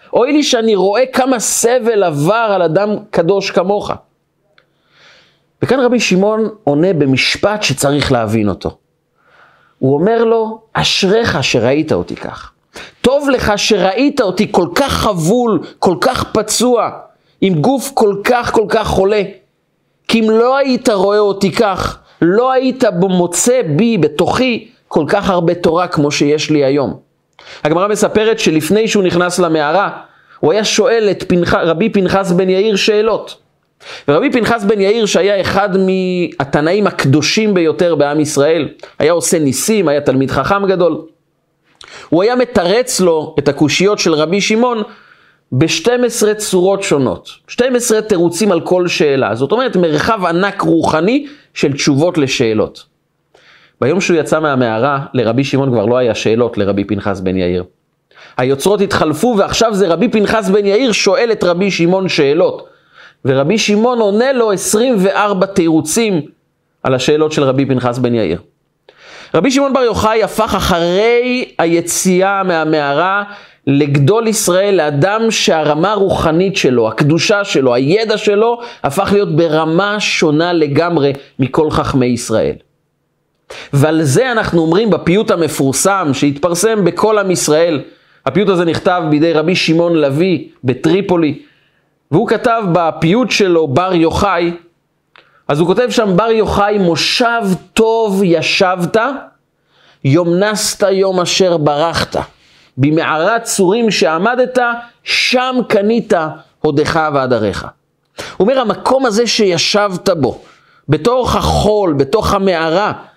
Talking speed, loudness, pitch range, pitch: 130 wpm, -13 LUFS, 155-220 Hz, 190 Hz